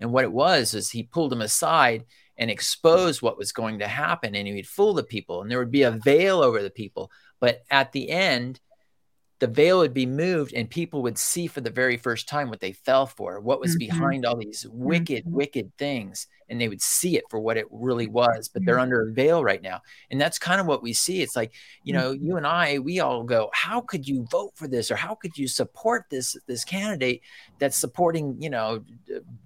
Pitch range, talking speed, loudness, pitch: 115-165 Hz, 230 wpm, -24 LUFS, 130 Hz